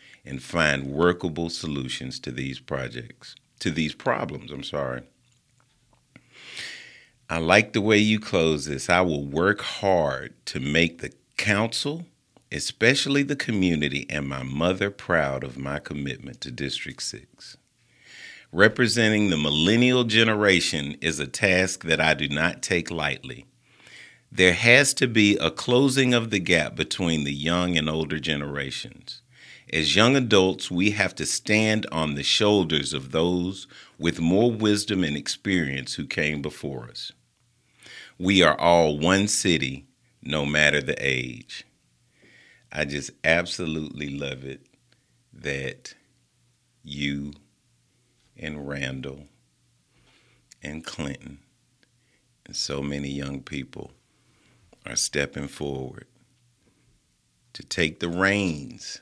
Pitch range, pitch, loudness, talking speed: 70-105 Hz, 80 Hz, -23 LUFS, 125 wpm